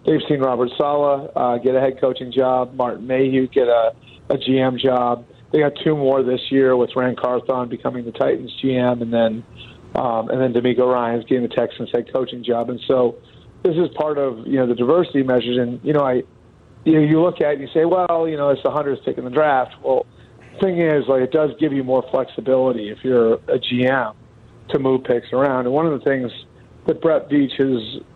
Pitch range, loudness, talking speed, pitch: 125-140 Hz, -19 LUFS, 220 wpm, 130 Hz